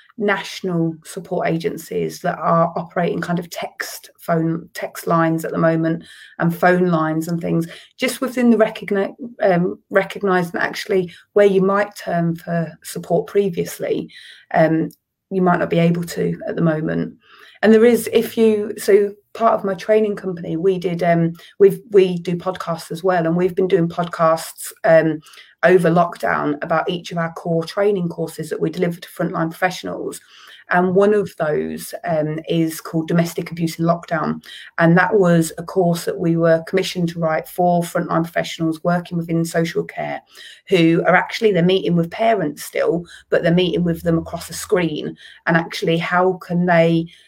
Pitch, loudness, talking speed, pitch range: 175 Hz, -19 LUFS, 170 wpm, 165-195 Hz